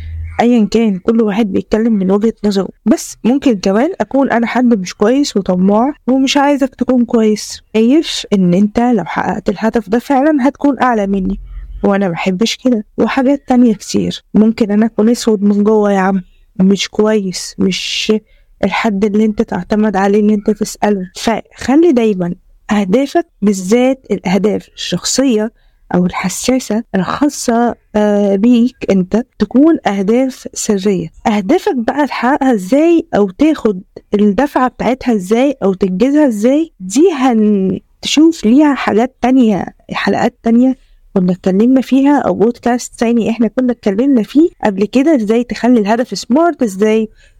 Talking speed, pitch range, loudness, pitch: 135 wpm, 205-255 Hz, -13 LUFS, 225 Hz